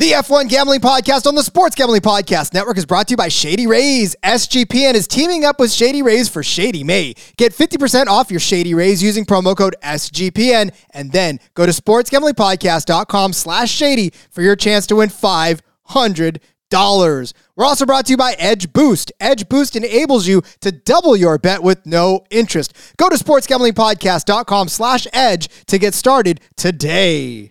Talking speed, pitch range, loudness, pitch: 170 wpm, 180-255 Hz, -13 LUFS, 210 Hz